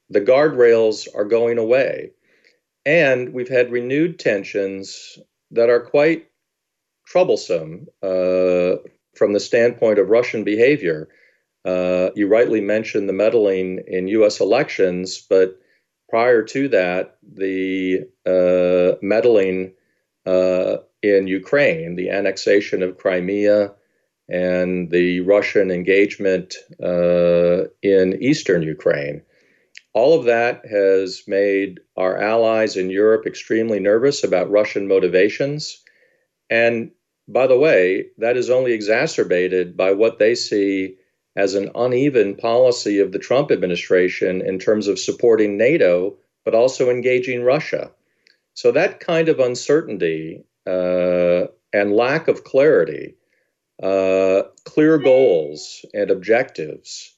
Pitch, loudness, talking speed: 105 Hz, -18 LUFS, 115 wpm